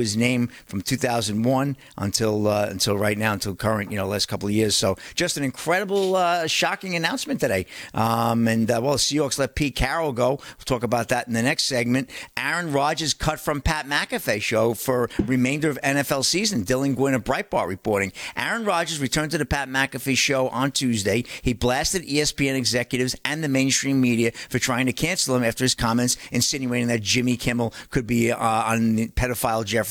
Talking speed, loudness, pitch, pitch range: 195 wpm, -23 LUFS, 125 Hz, 115-145 Hz